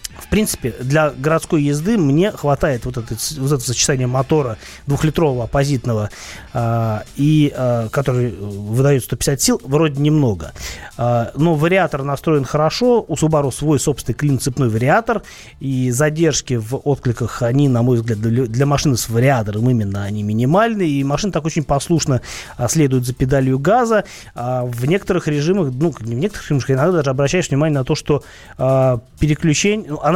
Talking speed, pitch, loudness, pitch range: 145 wpm, 140 Hz, -17 LUFS, 120-155 Hz